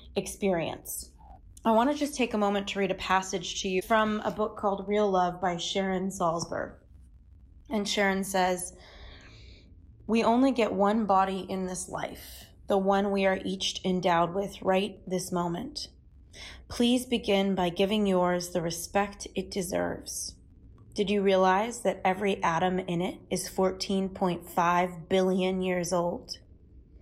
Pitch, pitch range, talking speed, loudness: 190 Hz, 175-200 Hz, 145 wpm, -28 LUFS